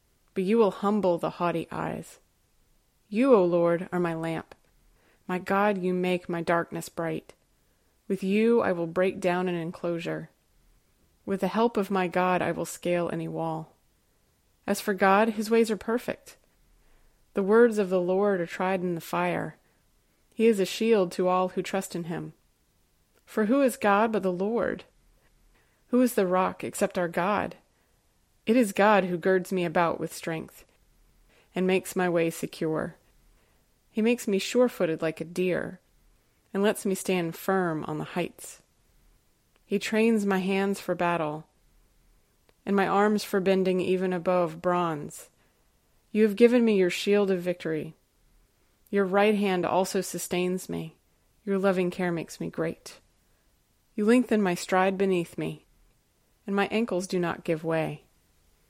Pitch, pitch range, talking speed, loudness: 185 Hz, 175-200 Hz, 160 wpm, -27 LUFS